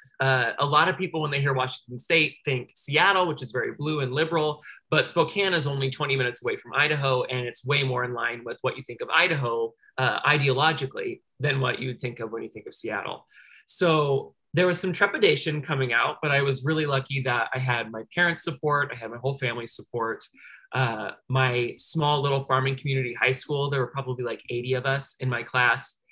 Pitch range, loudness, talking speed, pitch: 125-150 Hz, -25 LUFS, 215 wpm, 135 Hz